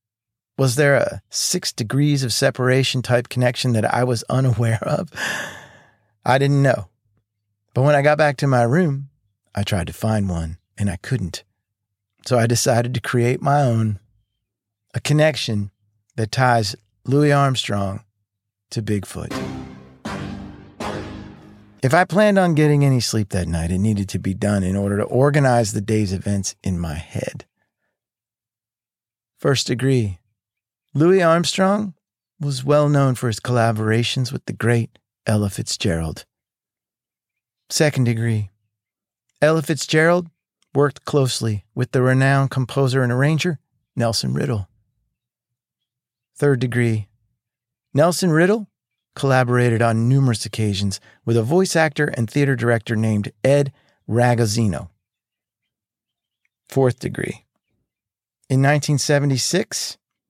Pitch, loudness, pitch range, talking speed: 120 Hz, -19 LUFS, 105-135 Hz, 120 wpm